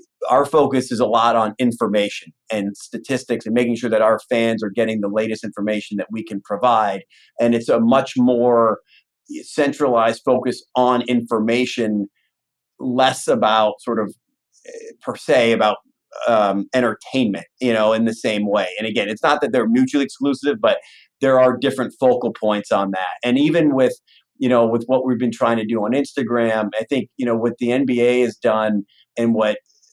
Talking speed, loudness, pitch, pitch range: 180 wpm, -19 LUFS, 120 Hz, 110-130 Hz